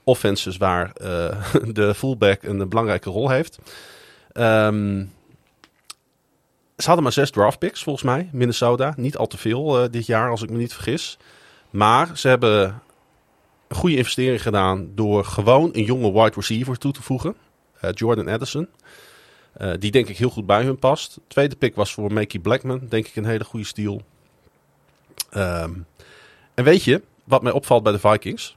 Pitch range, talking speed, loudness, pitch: 105-130 Hz, 170 wpm, -20 LUFS, 110 Hz